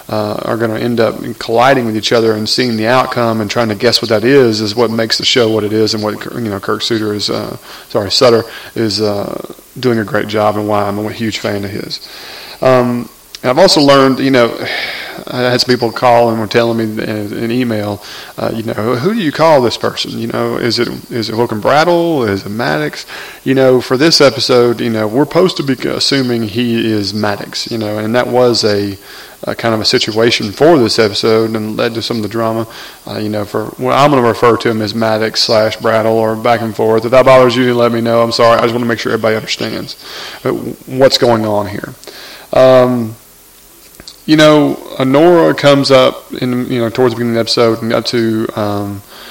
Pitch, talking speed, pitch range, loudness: 115 Hz, 230 wpm, 110-125 Hz, -12 LUFS